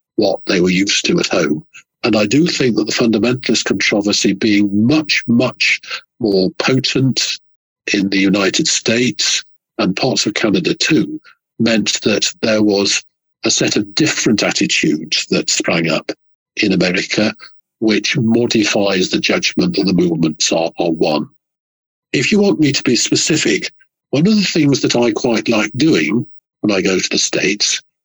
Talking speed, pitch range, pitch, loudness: 160 wpm, 100-135 Hz, 115 Hz, -14 LUFS